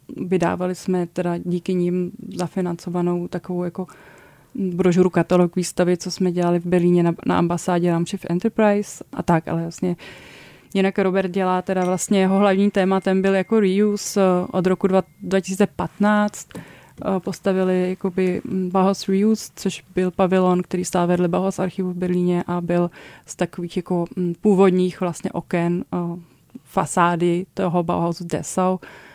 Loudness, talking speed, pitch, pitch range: -21 LUFS, 135 wpm, 180 Hz, 175-190 Hz